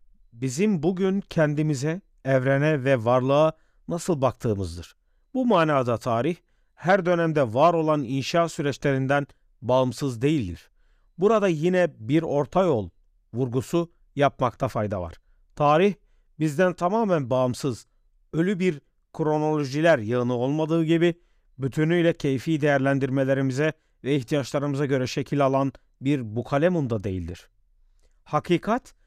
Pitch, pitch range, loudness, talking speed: 145 Hz, 125-165 Hz, -24 LUFS, 105 wpm